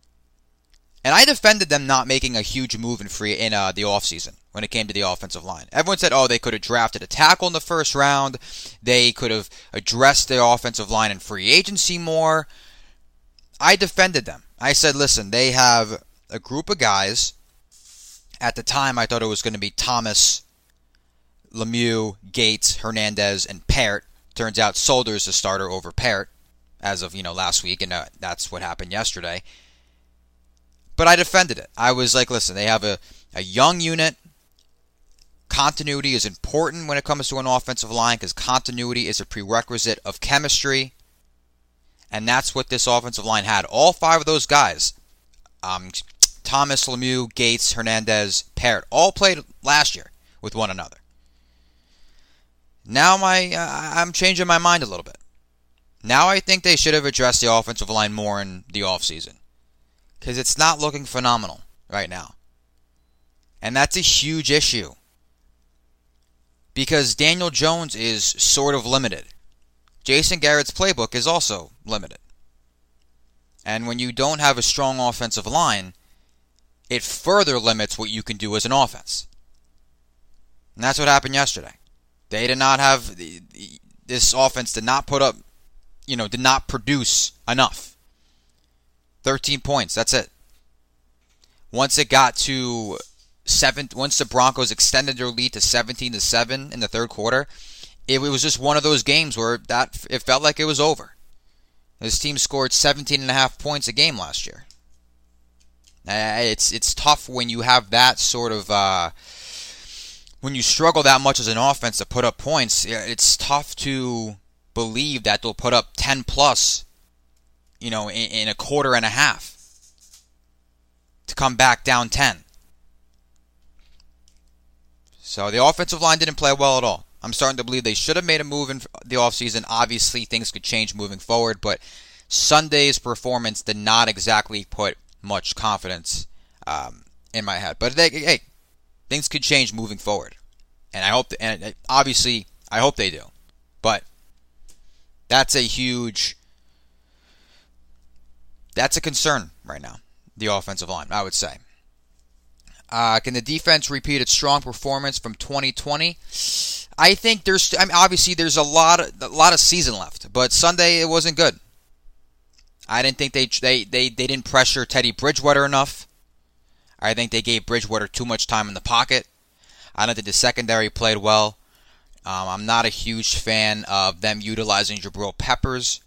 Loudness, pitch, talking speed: -19 LUFS, 110 Hz, 165 wpm